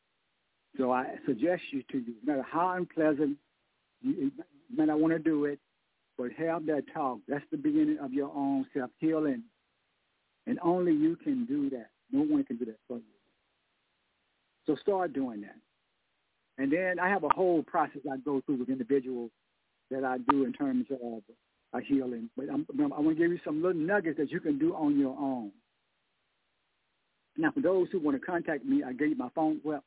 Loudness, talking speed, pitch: -31 LUFS, 195 wpm, 155 Hz